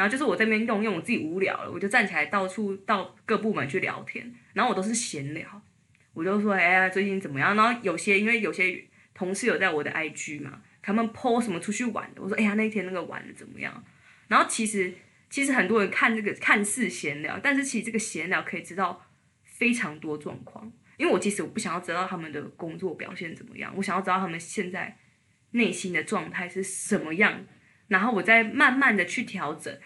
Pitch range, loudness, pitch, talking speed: 180-225 Hz, -26 LUFS, 195 Hz, 340 characters per minute